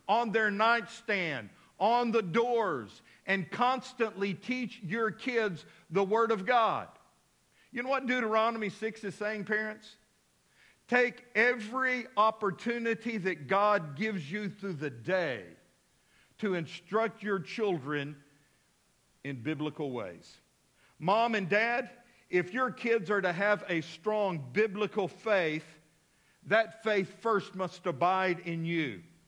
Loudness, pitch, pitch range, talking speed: -31 LUFS, 205 Hz, 175-225 Hz, 125 wpm